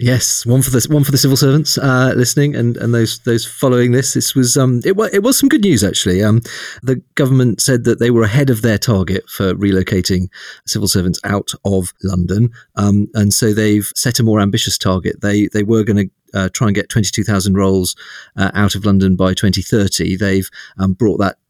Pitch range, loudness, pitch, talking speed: 95-125 Hz, -14 LUFS, 110 Hz, 220 wpm